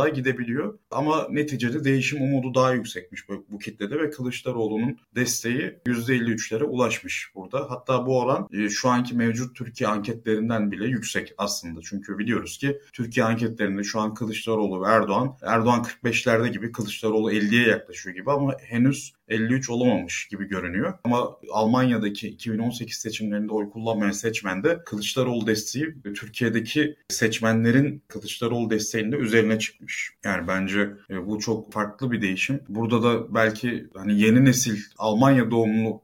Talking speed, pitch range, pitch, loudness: 135 wpm, 105-125 Hz, 115 Hz, -24 LUFS